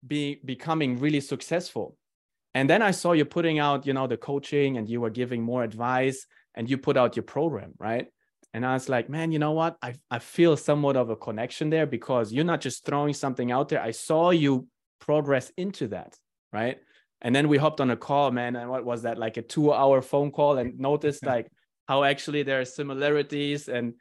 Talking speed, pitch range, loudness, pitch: 210 wpm, 125-150 Hz, -26 LUFS, 140 Hz